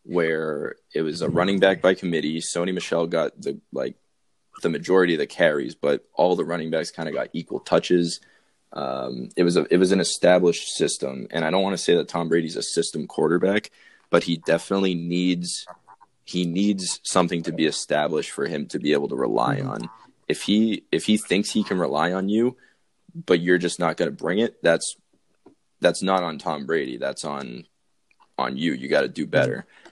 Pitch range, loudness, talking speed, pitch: 85-95 Hz, -23 LUFS, 200 wpm, 90 Hz